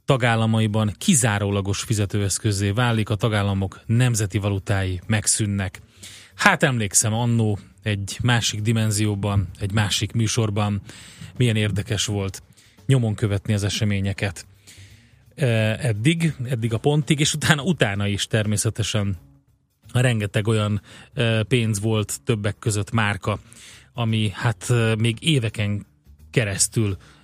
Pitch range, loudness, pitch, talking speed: 100-115 Hz, -22 LUFS, 110 Hz, 100 wpm